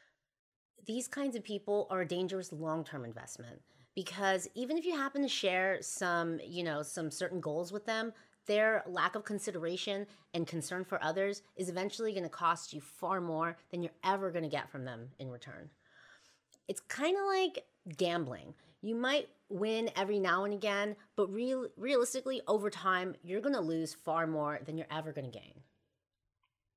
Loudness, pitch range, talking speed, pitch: -36 LUFS, 165-215 Hz, 175 wpm, 190 Hz